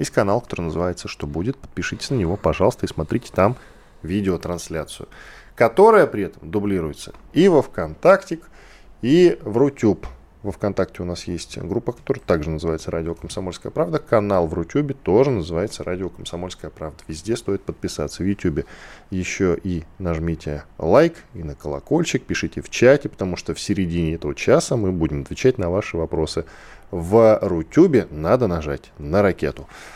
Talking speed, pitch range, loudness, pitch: 155 wpm, 80-105 Hz, -21 LUFS, 90 Hz